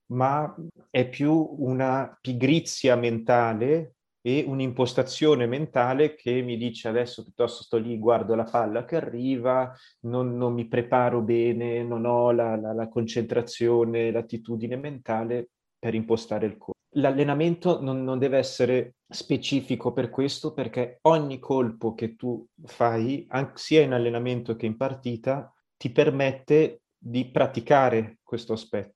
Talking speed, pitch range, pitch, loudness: 135 wpm, 120-135 Hz, 125 Hz, -26 LUFS